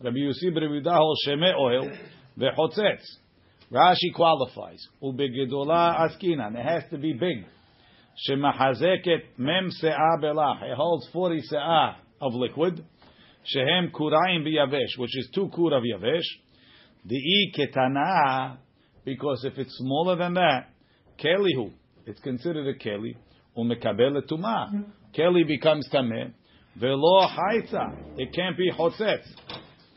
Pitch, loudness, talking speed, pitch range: 150 Hz, -25 LUFS, 115 wpm, 130-170 Hz